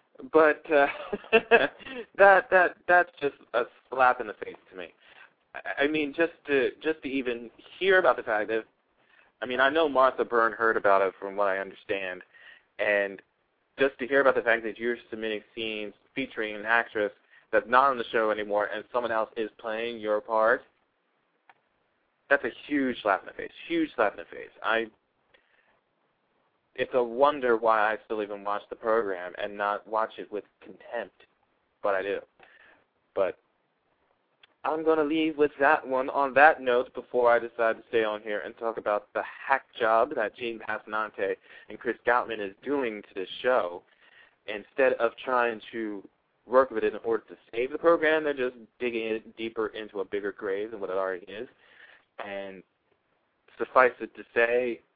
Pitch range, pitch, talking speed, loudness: 110-160 Hz, 120 Hz, 180 wpm, -27 LUFS